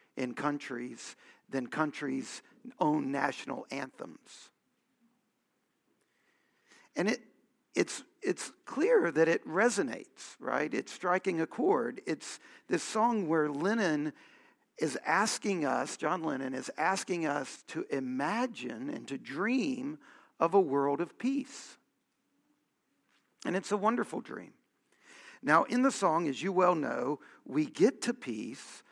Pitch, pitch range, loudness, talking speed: 235 Hz, 160-270 Hz, -32 LUFS, 125 wpm